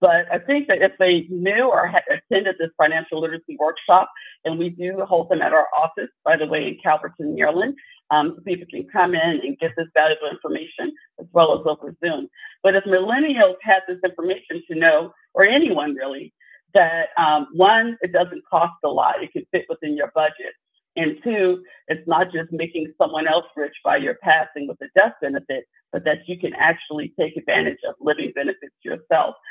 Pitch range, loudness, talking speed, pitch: 160-195 Hz, -20 LUFS, 195 wpm, 175 Hz